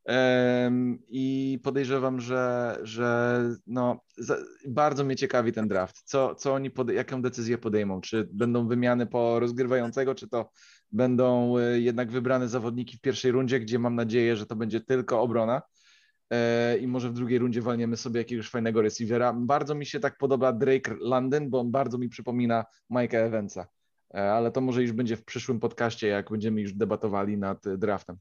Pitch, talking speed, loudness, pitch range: 120 Hz, 165 wpm, -27 LUFS, 115-130 Hz